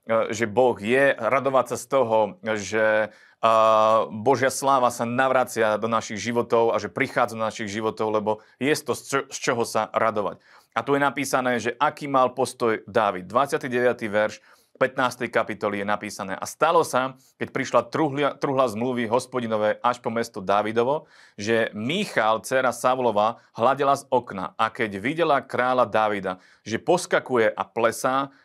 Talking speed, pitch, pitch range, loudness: 150 wpm, 120 Hz, 110-130 Hz, -23 LUFS